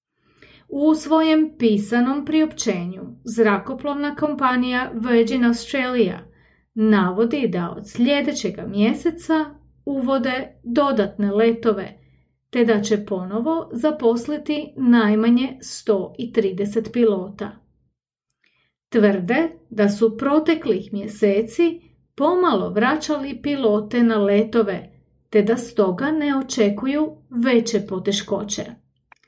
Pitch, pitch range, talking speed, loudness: 235 Hz, 210-280 Hz, 85 wpm, -20 LUFS